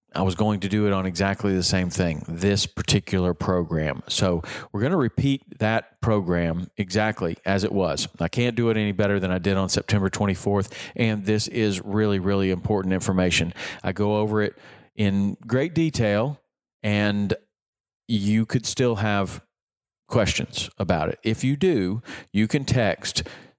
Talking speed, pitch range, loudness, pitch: 165 wpm, 95-110 Hz, -24 LUFS, 105 Hz